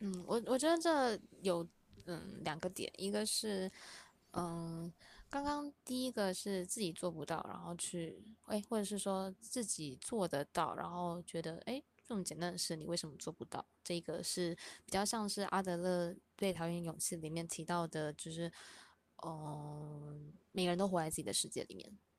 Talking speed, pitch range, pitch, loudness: 250 characters per minute, 165-205 Hz, 175 Hz, -40 LUFS